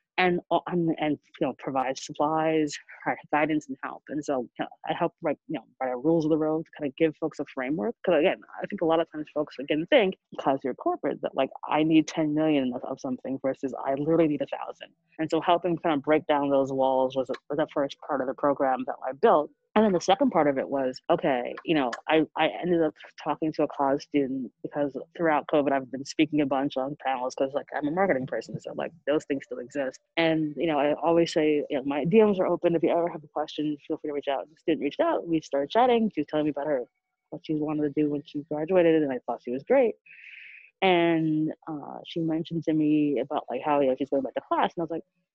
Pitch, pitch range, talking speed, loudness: 155 Hz, 140-165 Hz, 255 wpm, -27 LUFS